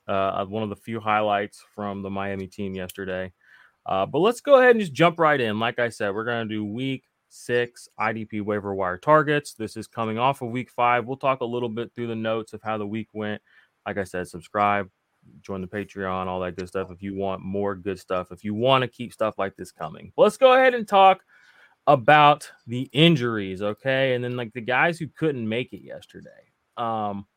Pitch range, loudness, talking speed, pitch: 100-130 Hz, -23 LUFS, 220 wpm, 110 Hz